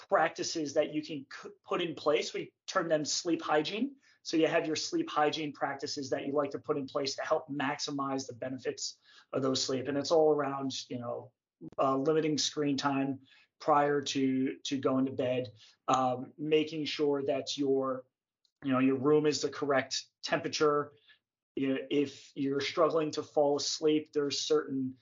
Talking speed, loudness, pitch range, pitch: 175 wpm, -32 LUFS, 135-155 Hz, 145 Hz